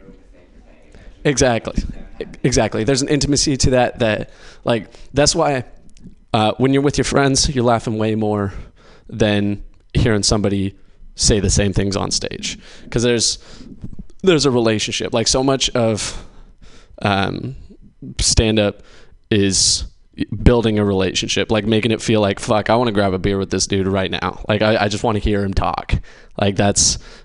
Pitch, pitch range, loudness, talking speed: 110 Hz, 100-120 Hz, -17 LUFS, 165 wpm